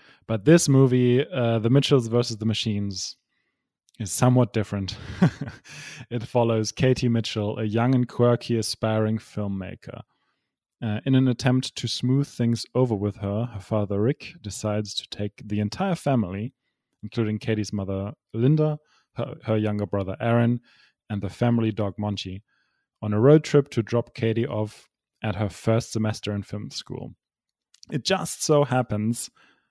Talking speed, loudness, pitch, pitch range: 150 wpm, -24 LUFS, 115 Hz, 105-125 Hz